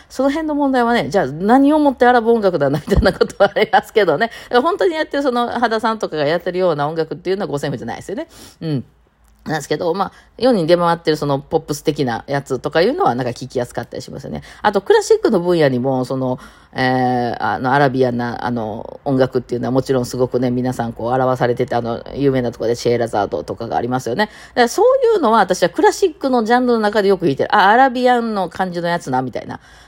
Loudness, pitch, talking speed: -17 LUFS, 165 Hz, 500 characters per minute